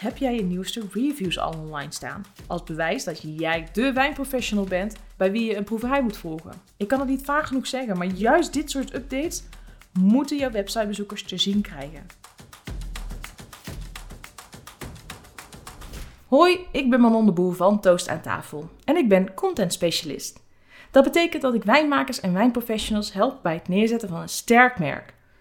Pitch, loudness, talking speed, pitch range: 215 Hz, -23 LUFS, 165 wpm, 180-260 Hz